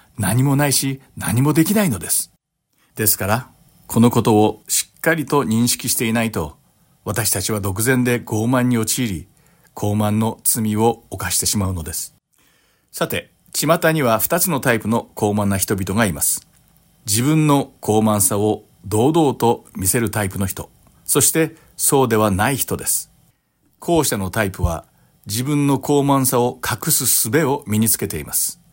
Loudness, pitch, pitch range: -18 LUFS, 115 Hz, 105-140 Hz